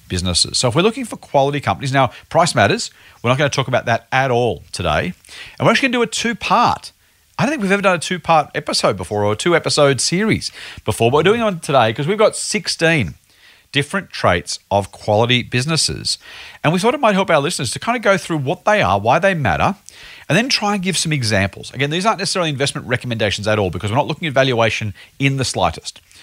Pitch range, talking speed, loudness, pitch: 115-185 Hz, 240 wpm, -17 LUFS, 140 Hz